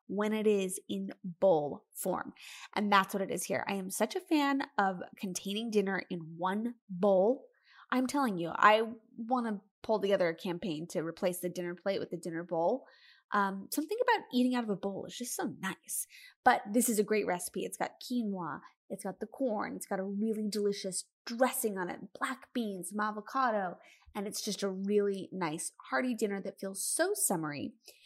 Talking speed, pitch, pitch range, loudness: 190 wpm, 205 Hz, 190-240 Hz, -33 LUFS